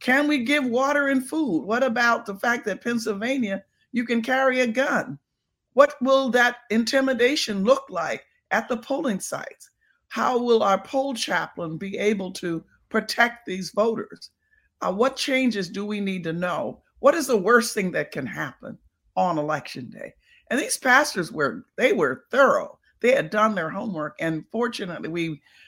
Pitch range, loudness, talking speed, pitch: 195-265 Hz, -23 LUFS, 170 wpm, 235 Hz